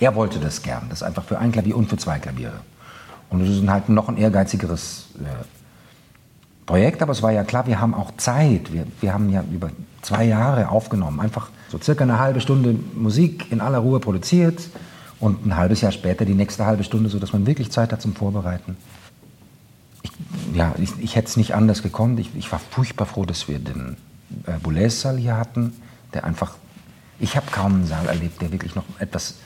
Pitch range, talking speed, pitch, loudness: 95-120 Hz, 205 wpm, 110 Hz, -21 LUFS